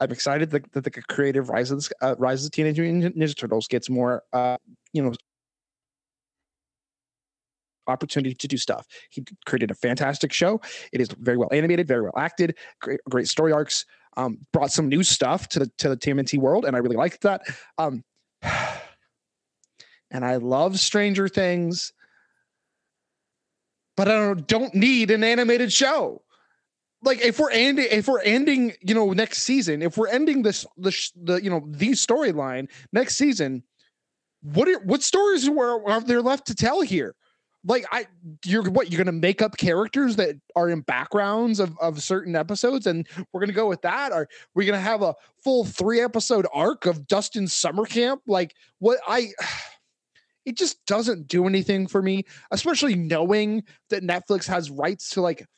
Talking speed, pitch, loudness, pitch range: 175 wpm, 185 Hz, -23 LUFS, 145-225 Hz